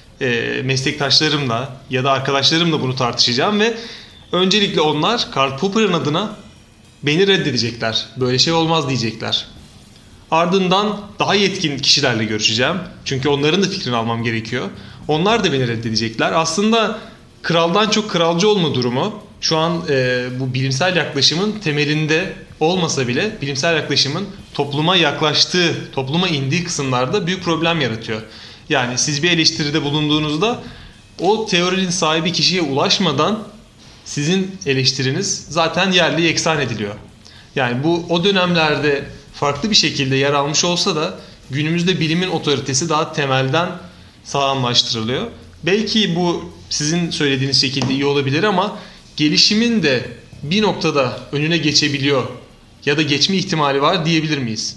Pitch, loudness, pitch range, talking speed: 150 Hz, -17 LUFS, 135-175 Hz, 120 wpm